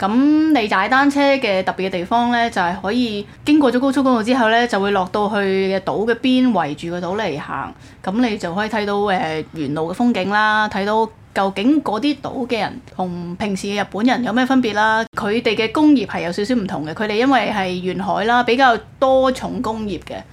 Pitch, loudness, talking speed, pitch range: 215 Hz, -18 LUFS, 310 characters per minute, 190-245 Hz